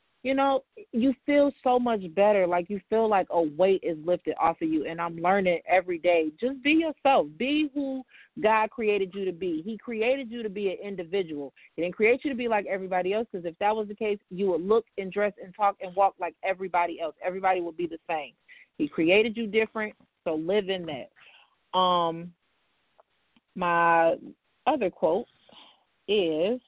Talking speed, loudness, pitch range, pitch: 190 wpm, -27 LUFS, 175-235 Hz, 200 Hz